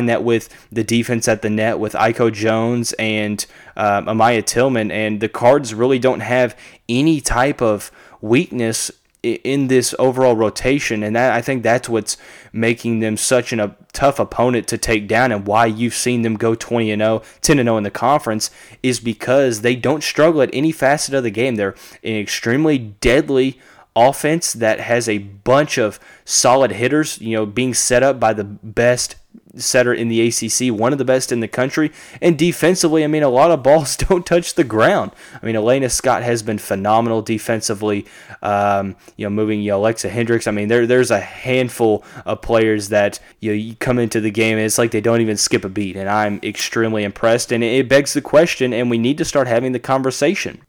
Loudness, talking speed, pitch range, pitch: -17 LUFS, 200 wpm, 110-130 Hz, 115 Hz